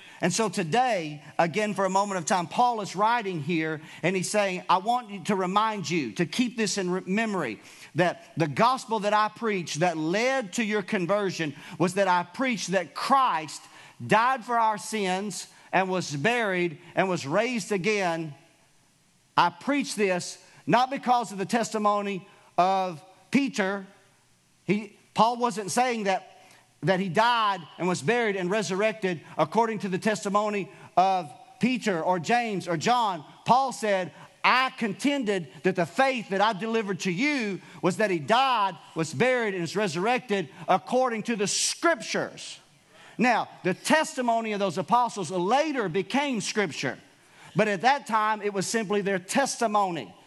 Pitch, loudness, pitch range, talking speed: 200 Hz, -26 LUFS, 180-225 Hz, 155 wpm